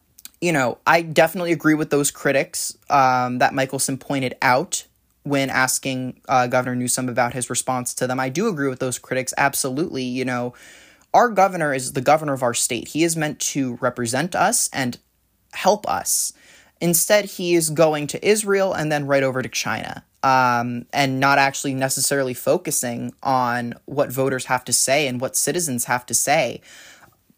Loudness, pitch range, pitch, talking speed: -20 LUFS, 125-150 Hz, 135 Hz, 175 wpm